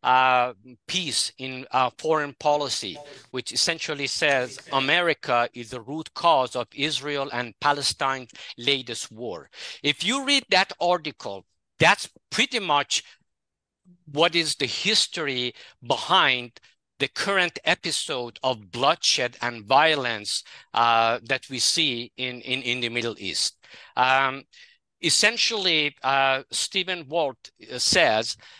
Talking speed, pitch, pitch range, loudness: 115 wpm, 135 Hz, 120-155 Hz, -23 LUFS